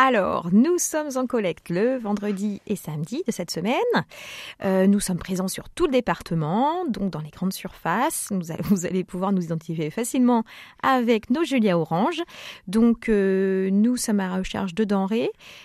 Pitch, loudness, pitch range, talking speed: 205 Hz, -24 LUFS, 185-245 Hz, 170 wpm